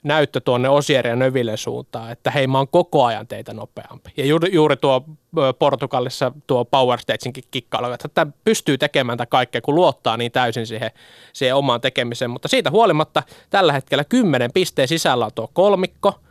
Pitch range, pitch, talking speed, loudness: 125-155 Hz, 140 Hz, 170 wpm, -19 LUFS